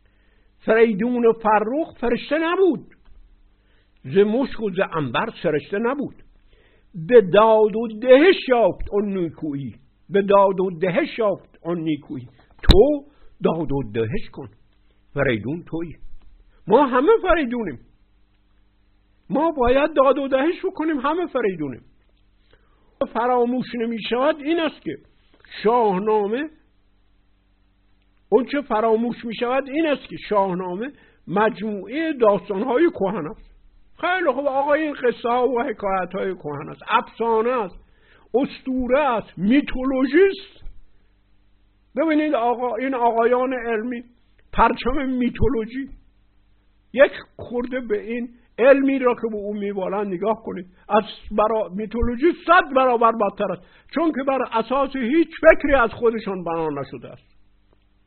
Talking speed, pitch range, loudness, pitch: 120 wpm, 155-260 Hz, -21 LUFS, 220 Hz